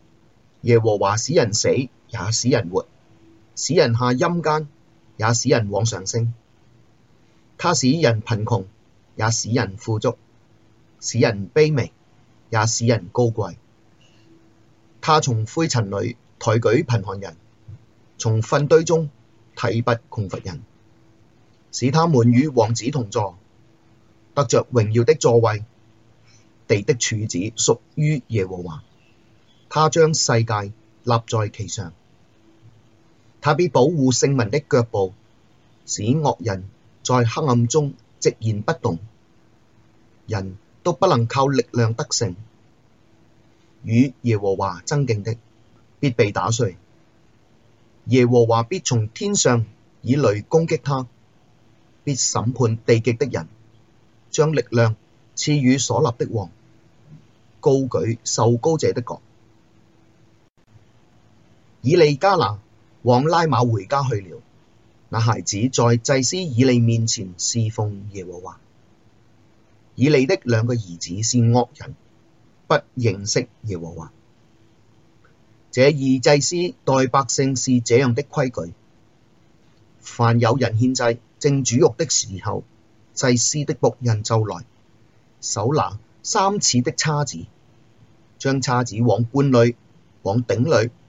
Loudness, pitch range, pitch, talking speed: -20 LUFS, 110-130 Hz, 115 Hz, 170 characters per minute